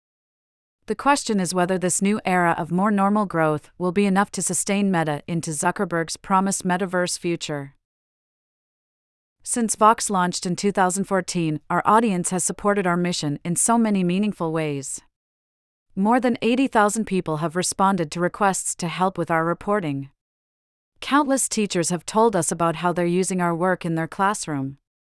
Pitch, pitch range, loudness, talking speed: 180 Hz, 165-200 Hz, -22 LUFS, 155 wpm